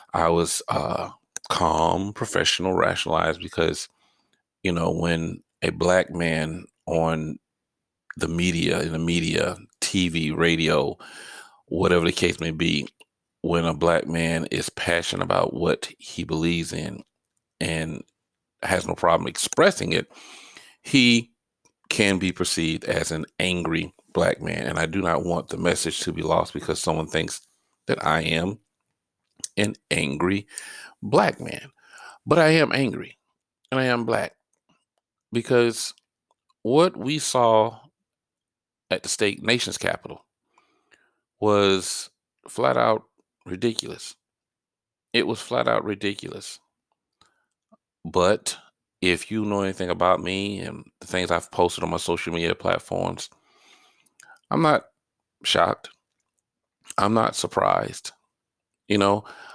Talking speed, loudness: 125 wpm, -23 LUFS